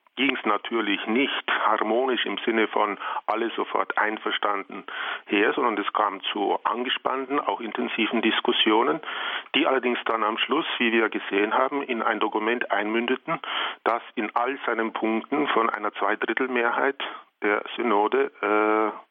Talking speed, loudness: 140 wpm, -24 LUFS